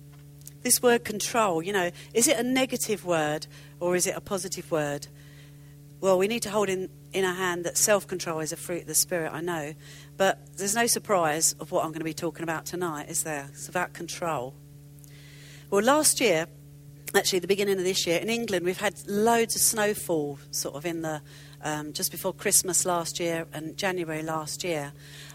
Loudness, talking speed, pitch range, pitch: -26 LUFS, 195 wpm, 145-190 Hz, 165 Hz